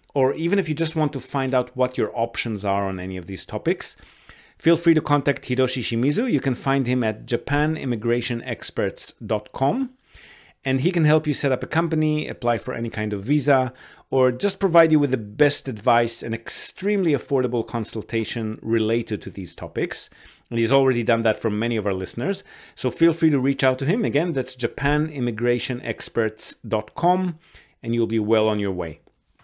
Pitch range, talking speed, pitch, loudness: 115-145 Hz, 180 wpm, 125 Hz, -23 LUFS